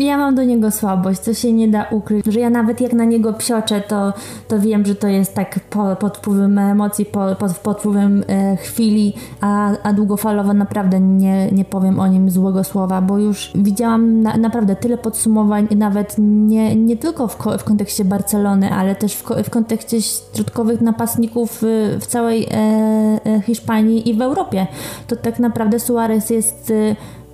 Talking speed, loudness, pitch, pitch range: 180 wpm, -16 LUFS, 210 Hz, 200-225 Hz